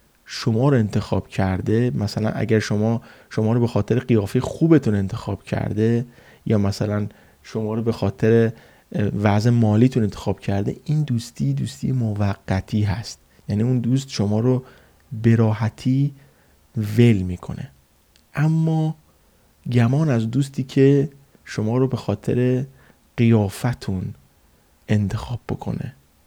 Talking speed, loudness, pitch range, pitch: 115 wpm, -21 LUFS, 100-125 Hz, 110 Hz